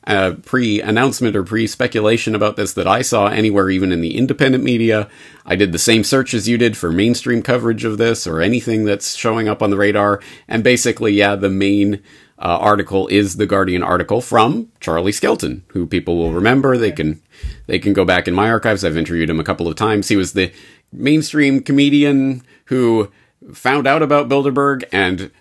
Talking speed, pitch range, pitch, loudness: 195 wpm, 95-120 Hz, 105 Hz, -16 LUFS